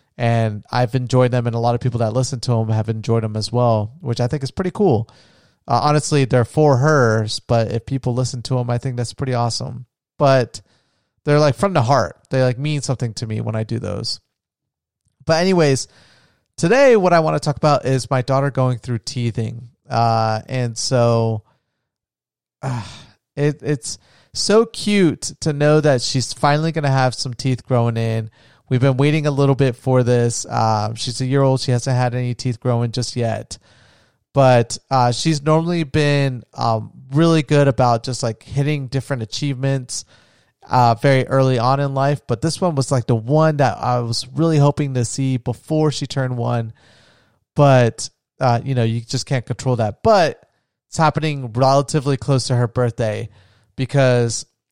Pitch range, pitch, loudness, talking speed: 115-140 Hz, 125 Hz, -18 LUFS, 185 wpm